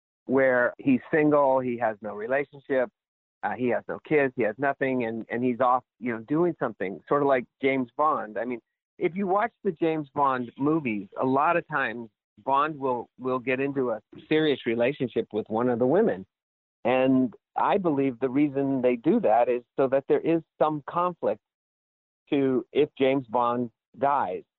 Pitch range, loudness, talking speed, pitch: 125-150 Hz, -26 LUFS, 180 wpm, 135 Hz